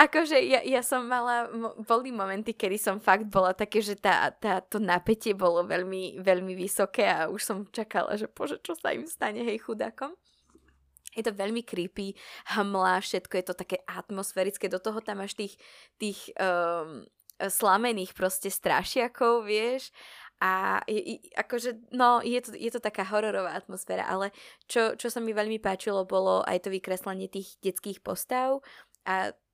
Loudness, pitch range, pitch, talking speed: -29 LUFS, 190-230 Hz, 205 Hz, 165 wpm